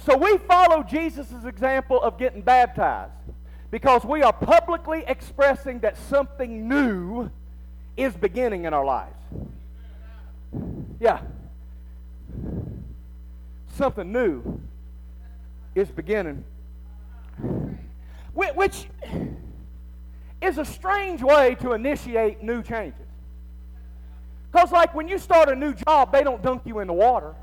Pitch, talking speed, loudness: 180 Hz, 110 wpm, -22 LUFS